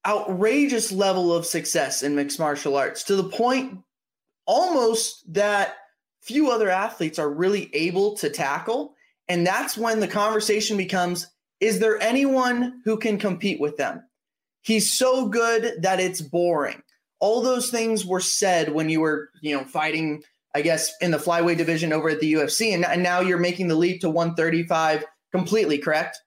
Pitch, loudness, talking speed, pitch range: 185 Hz, -23 LUFS, 165 wpm, 160-220 Hz